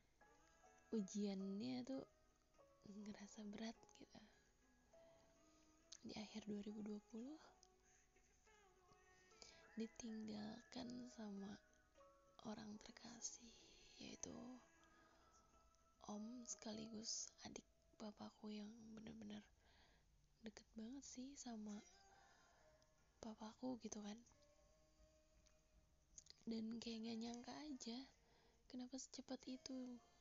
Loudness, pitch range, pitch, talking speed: -55 LUFS, 210-255 Hz, 225 Hz, 70 wpm